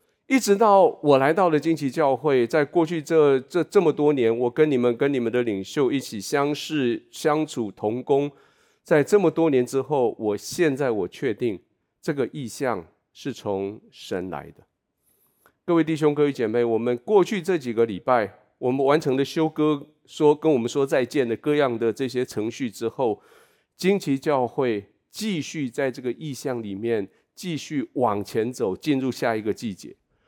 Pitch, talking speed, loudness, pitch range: 140 Hz, 250 characters per minute, -23 LUFS, 120-155 Hz